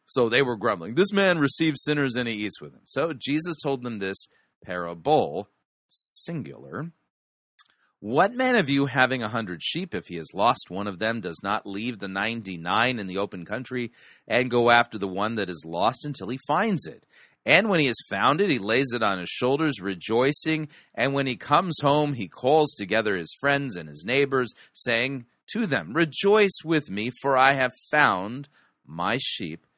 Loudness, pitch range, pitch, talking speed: -24 LUFS, 110-150 Hz, 130 Hz, 190 wpm